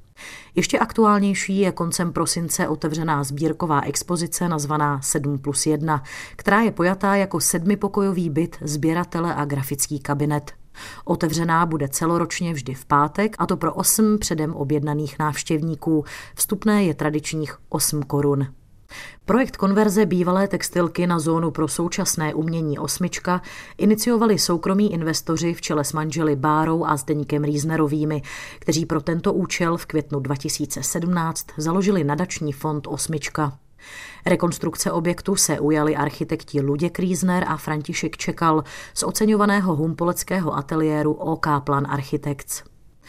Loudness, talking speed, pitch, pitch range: -22 LUFS, 125 wpm, 160 Hz, 150-175 Hz